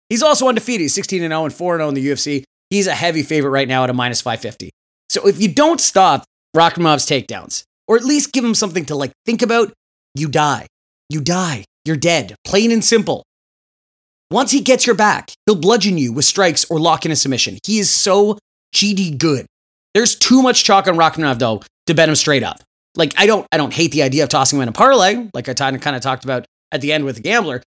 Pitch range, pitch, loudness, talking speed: 140-210 Hz, 165 Hz, -15 LUFS, 225 wpm